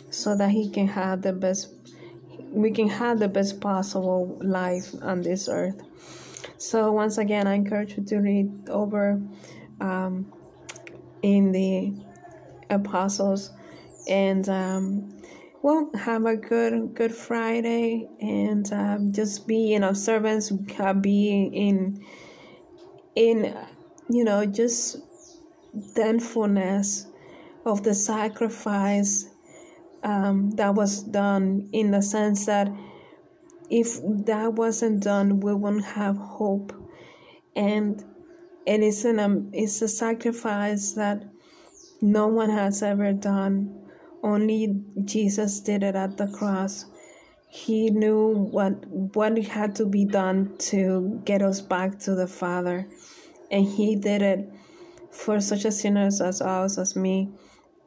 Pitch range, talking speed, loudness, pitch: 195-225 Hz, 125 wpm, -25 LUFS, 205 Hz